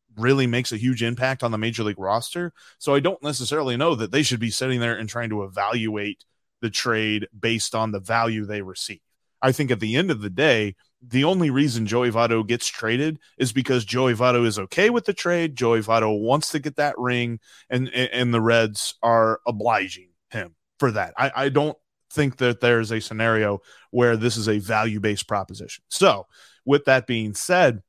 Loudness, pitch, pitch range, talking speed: -22 LUFS, 120 Hz, 110-135 Hz, 200 wpm